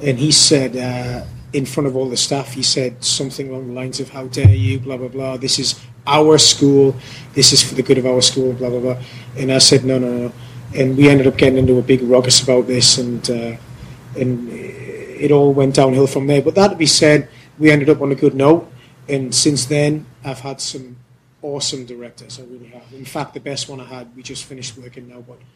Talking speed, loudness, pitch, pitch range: 235 wpm, -14 LUFS, 130 Hz, 125-140 Hz